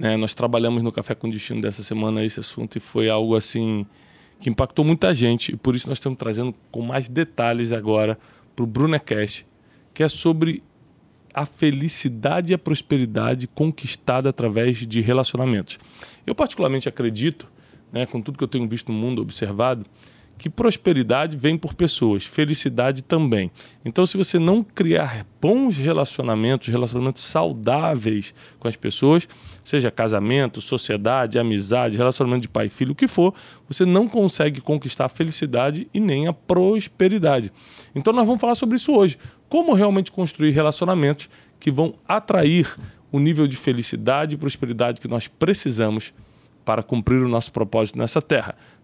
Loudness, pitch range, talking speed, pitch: -21 LUFS, 115-155 Hz, 155 wpm, 130 Hz